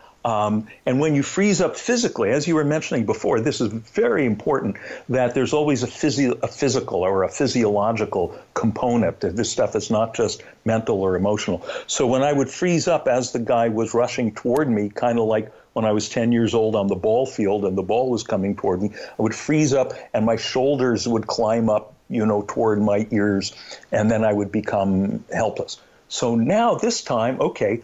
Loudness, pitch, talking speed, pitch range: -21 LUFS, 115 Hz, 205 wpm, 110-135 Hz